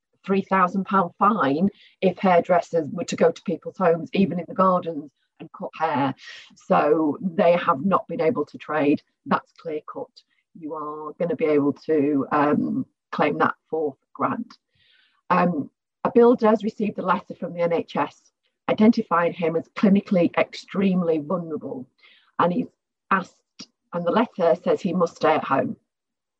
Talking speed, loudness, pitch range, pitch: 155 wpm, -23 LUFS, 165-205 Hz, 180 Hz